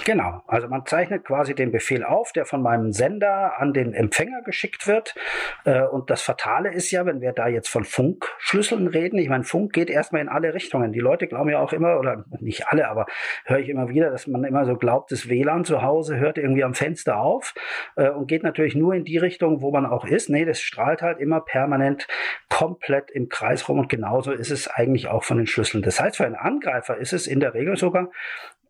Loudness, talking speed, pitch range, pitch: -22 LUFS, 220 wpm, 130-170 Hz, 145 Hz